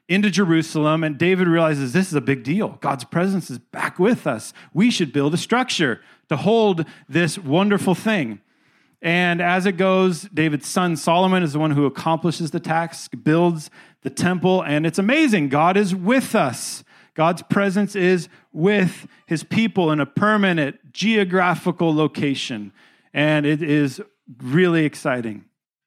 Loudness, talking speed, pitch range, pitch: -20 LUFS, 155 wpm, 150-190 Hz, 170 Hz